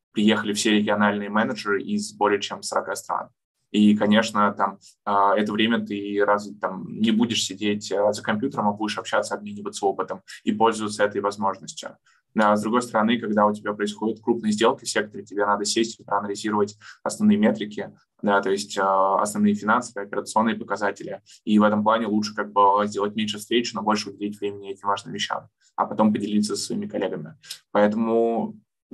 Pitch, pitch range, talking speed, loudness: 105 Hz, 100-110 Hz, 165 wpm, -23 LUFS